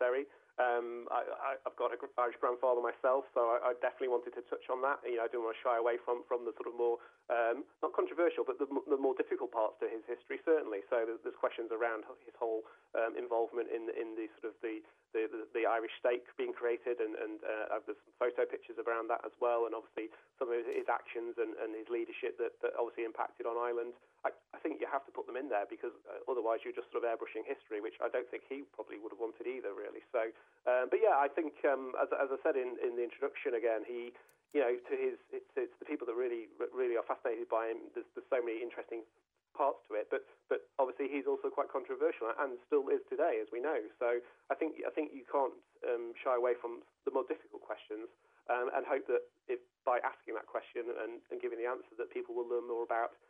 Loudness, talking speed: -37 LUFS, 240 wpm